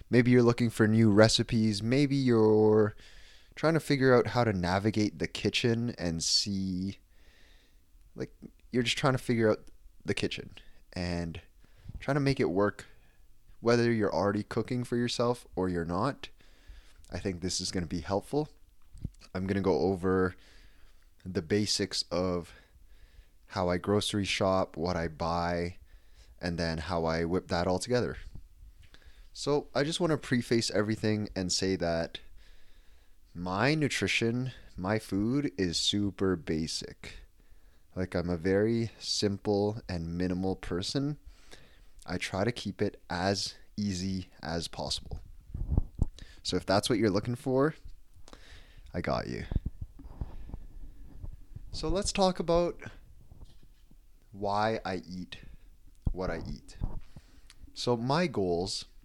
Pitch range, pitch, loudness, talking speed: 85-115 Hz, 95 Hz, -30 LUFS, 135 wpm